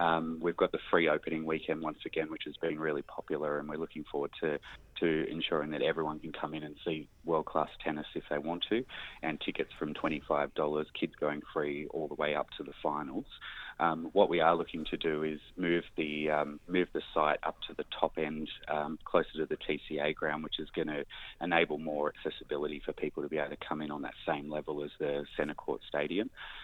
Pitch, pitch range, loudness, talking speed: 75 Hz, 75-80 Hz, -34 LUFS, 220 wpm